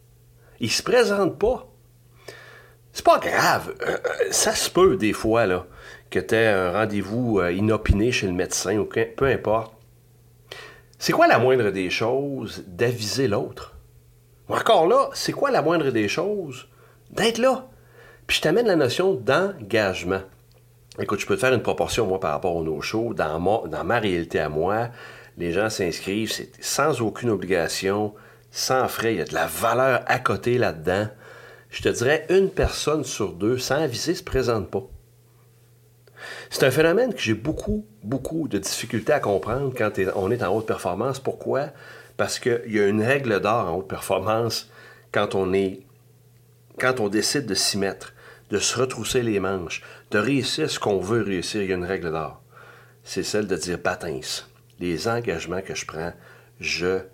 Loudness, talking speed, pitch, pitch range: -23 LUFS, 175 wpm, 115 Hz, 100-125 Hz